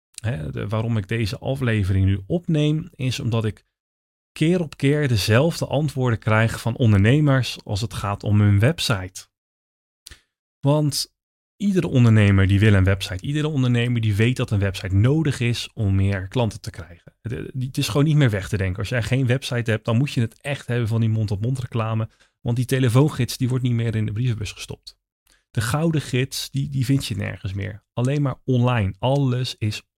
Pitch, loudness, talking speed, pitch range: 115 Hz, -22 LUFS, 190 wpm, 105-135 Hz